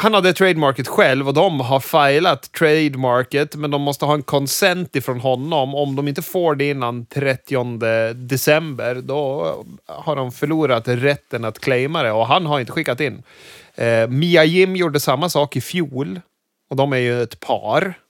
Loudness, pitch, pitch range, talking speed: -18 LUFS, 140 Hz, 130-155 Hz, 175 wpm